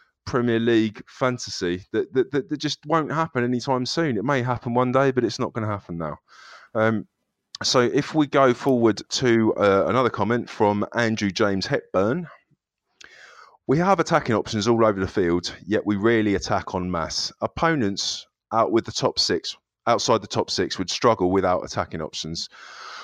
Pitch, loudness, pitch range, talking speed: 115 Hz, -23 LUFS, 100-130 Hz, 175 wpm